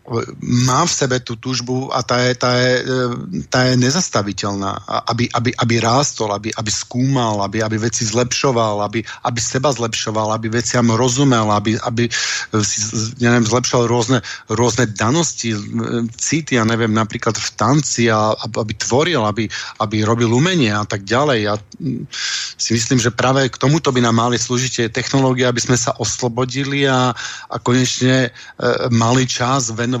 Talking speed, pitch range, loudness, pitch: 150 wpm, 115-125 Hz, -17 LUFS, 120 Hz